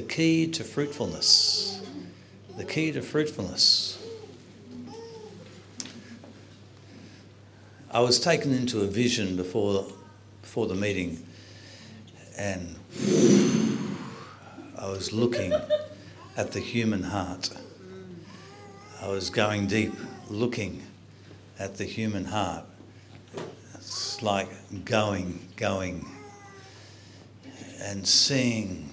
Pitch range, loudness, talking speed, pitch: 95-120 Hz, -26 LUFS, 85 wpm, 105 Hz